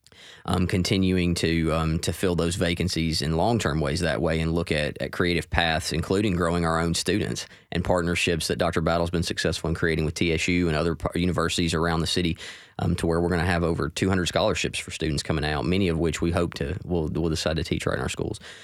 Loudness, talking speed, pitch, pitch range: -25 LUFS, 230 wpm, 85 Hz, 80-90 Hz